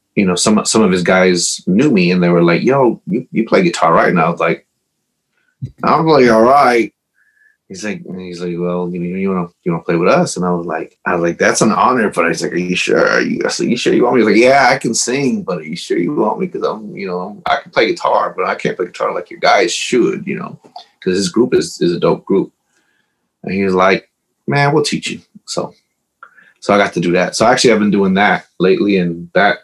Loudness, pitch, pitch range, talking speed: -14 LUFS, 90 Hz, 90-100 Hz, 265 wpm